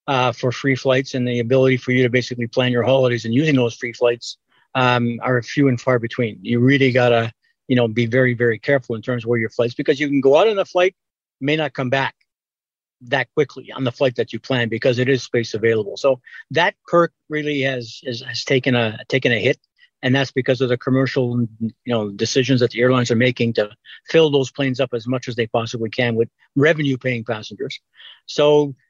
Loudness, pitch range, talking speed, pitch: -19 LUFS, 120-135 Hz, 220 wpm, 125 Hz